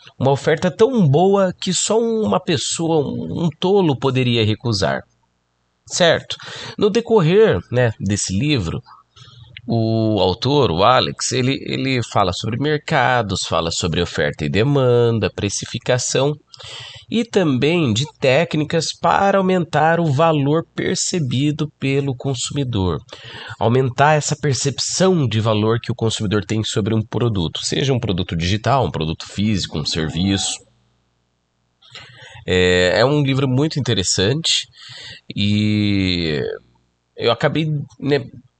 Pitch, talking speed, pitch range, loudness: 125 Hz, 115 wpm, 100-150 Hz, -18 LUFS